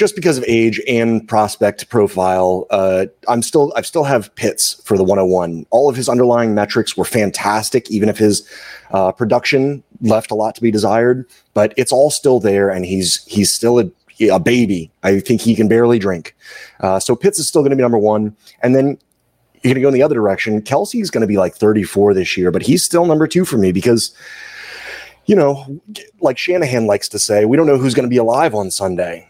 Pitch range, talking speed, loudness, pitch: 100-135 Hz, 215 wpm, -15 LUFS, 115 Hz